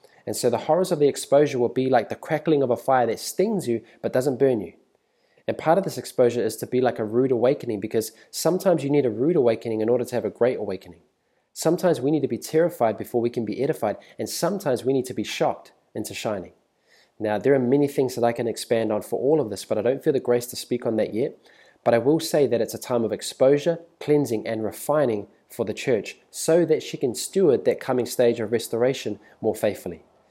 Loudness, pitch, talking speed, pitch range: -23 LUFS, 125 Hz, 240 wpm, 115-150 Hz